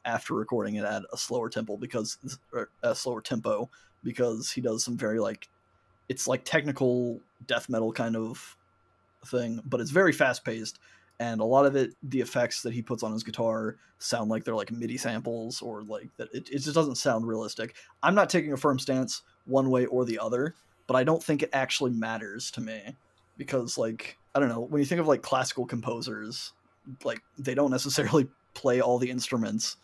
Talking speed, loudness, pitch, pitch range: 195 wpm, -29 LUFS, 120 Hz, 110-135 Hz